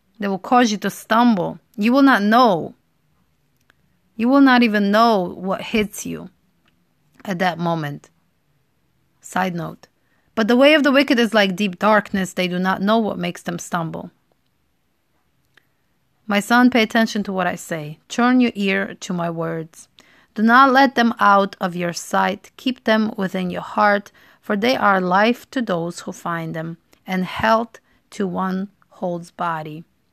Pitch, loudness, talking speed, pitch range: 200 Hz, -18 LUFS, 165 wpm, 180-230 Hz